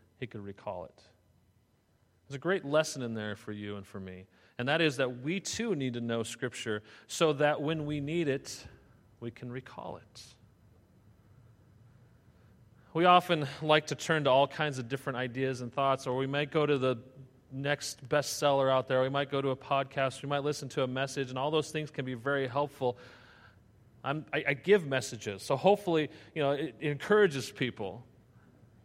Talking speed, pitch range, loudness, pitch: 190 wpm, 115-145 Hz, -31 LUFS, 130 Hz